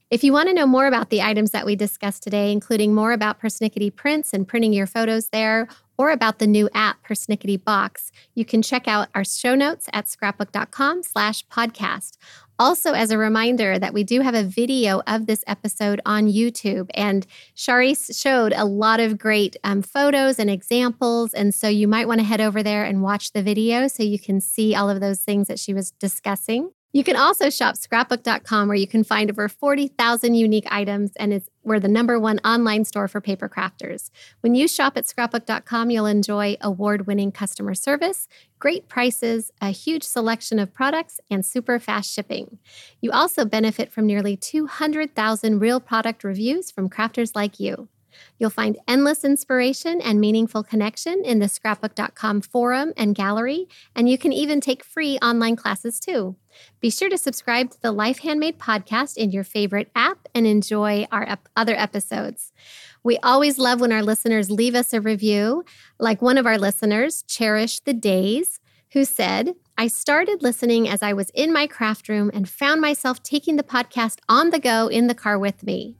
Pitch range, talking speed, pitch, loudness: 210-250 Hz, 185 wpm, 225 Hz, -21 LUFS